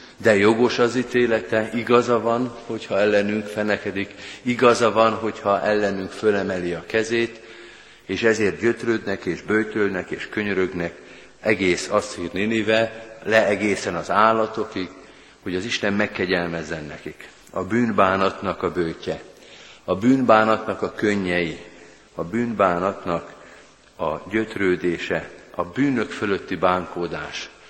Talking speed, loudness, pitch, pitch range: 110 wpm, -22 LUFS, 105 Hz, 90-110 Hz